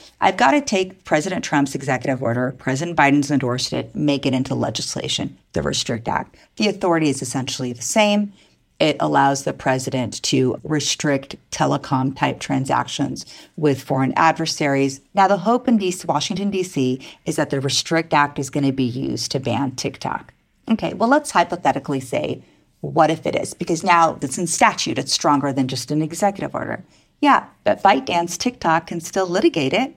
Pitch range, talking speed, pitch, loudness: 135-175 Hz, 170 wpm, 145 Hz, -20 LUFS